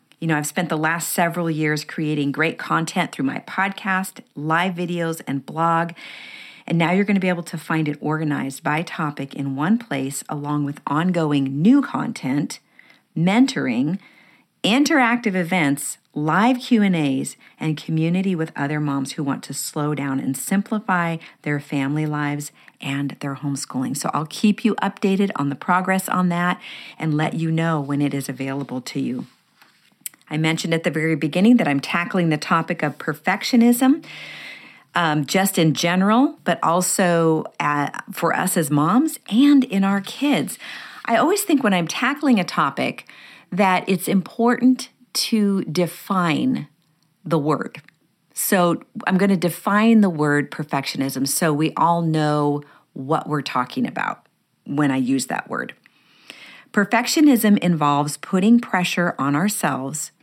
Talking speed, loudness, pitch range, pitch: 150 wpm, -20 LUFS, 150-200 Hz, 170 Hz